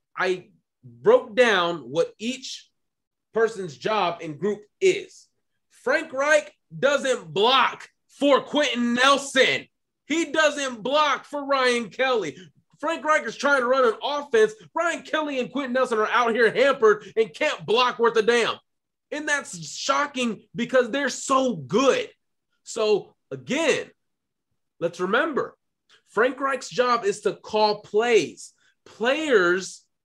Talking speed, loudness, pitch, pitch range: 130 wpm, -23 LUFS, 255 Hz, 215-290 Hz